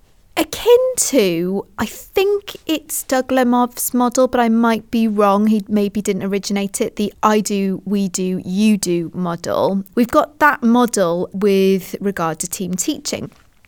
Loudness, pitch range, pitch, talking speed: -17 LUFS, 195-245 Hz, 210 Hz, 155 wpm